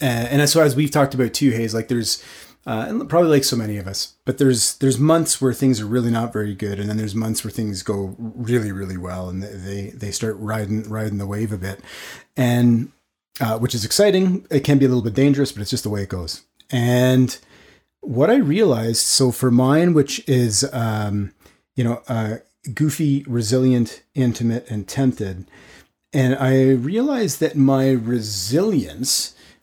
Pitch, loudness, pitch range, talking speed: 120 Hz, -19 LUFS, 105-135 Hz, 185 wpm